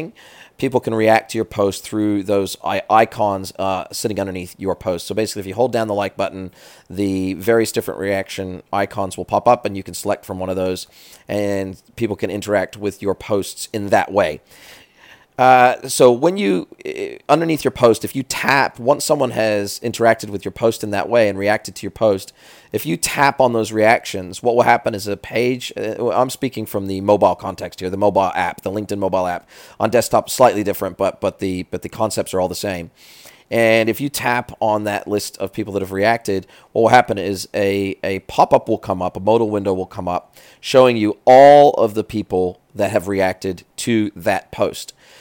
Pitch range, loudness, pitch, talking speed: 95-115 Hz, -18 LUFS, 105 Hz, 210 wpm